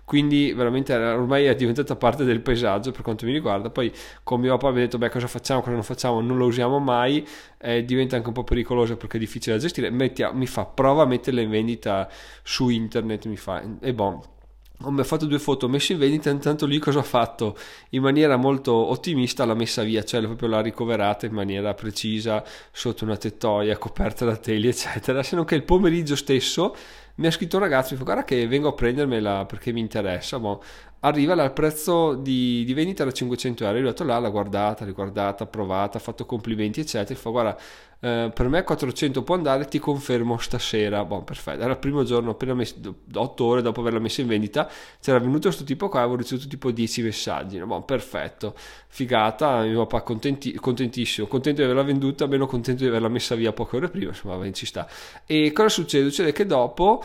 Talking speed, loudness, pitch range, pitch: 205 wpm, -24 LUFS, 110-135 Hz, 120 Hz